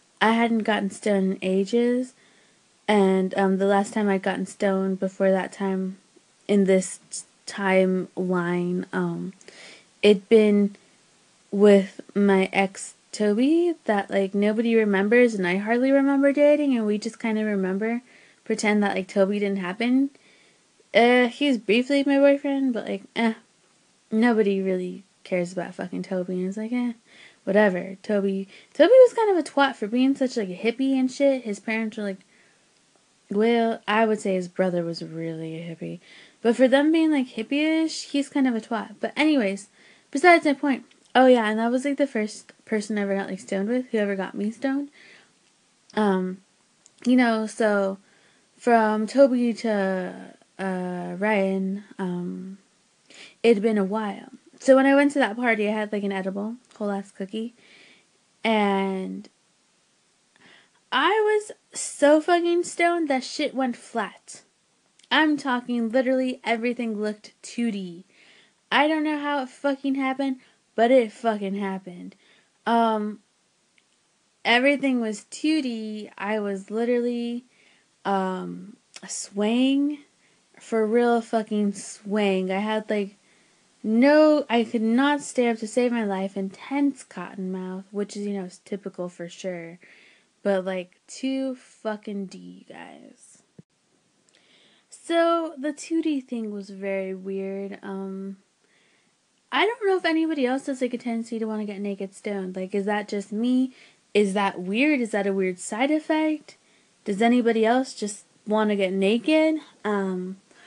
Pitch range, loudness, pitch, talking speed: 195-255 Hz, -23 LUFS, 215 Hz, 150 wpm